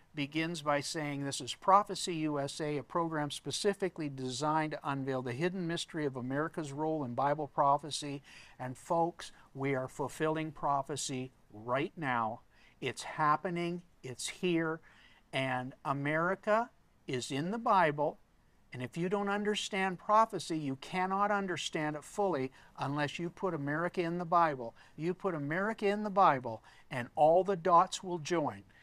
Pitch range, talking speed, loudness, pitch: 140-180 Hz, 145 wpm, -34 LUFS, 155 Hz